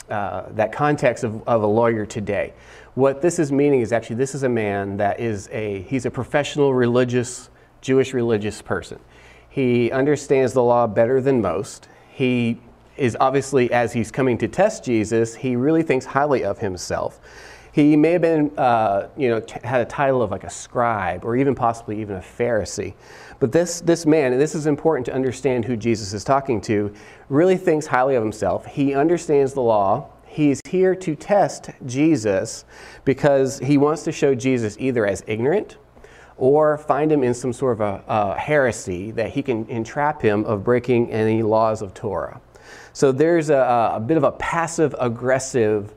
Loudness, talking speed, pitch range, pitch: -20 LUFS, 180 wpm, 115-145 Hz, 125 Hz